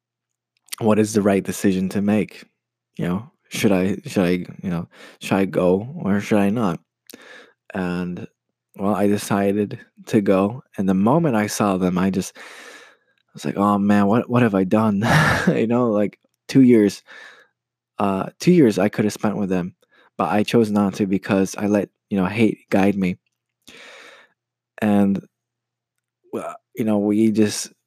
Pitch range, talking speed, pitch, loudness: 95-115 Hz, 170 wpm, 105 Hz, -20 LUFS